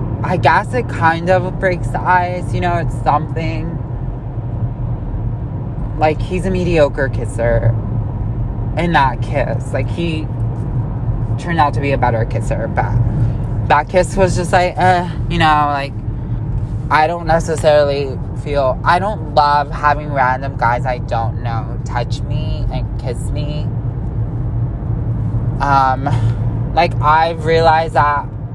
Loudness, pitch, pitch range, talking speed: -16 LUFS, 125 Hz, 115-145 Hz, 130 wpm